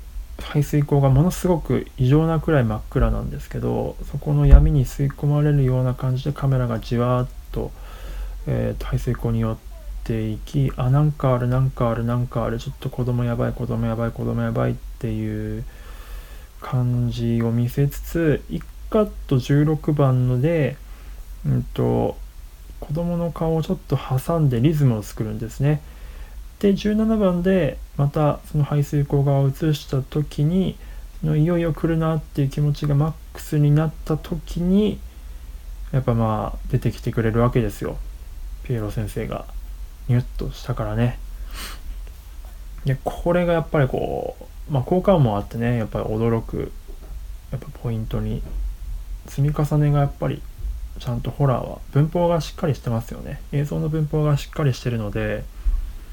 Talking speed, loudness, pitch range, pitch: 315 characters per minute, -22 LUFS, 110-150 Hz, 130 Hz